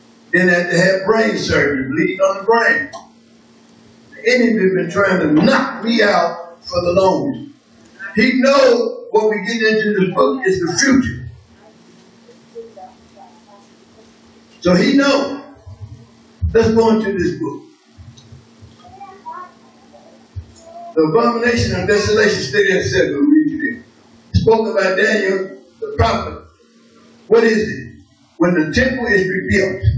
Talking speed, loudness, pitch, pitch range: 125 wpm, -15 LUFS, 220 Hz, 180-265 Hz